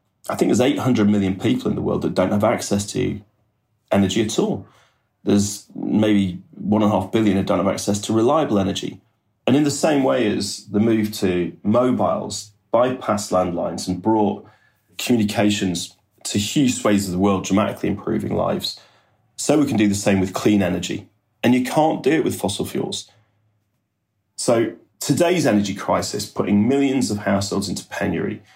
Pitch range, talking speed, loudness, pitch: 100-110 Hz, 170 wpm, -20 LUFS, 105 Hz